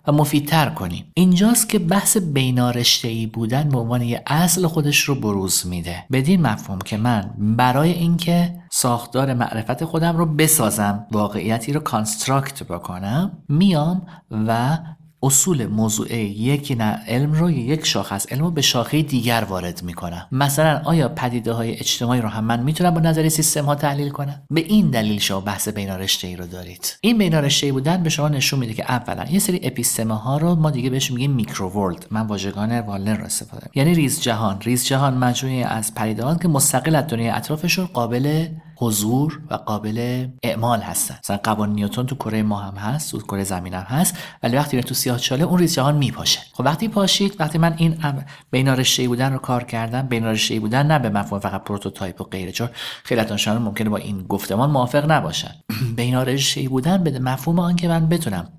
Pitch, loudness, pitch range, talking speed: 130 Hz, -20 LUFS, 110-155 Hz, 180 wpm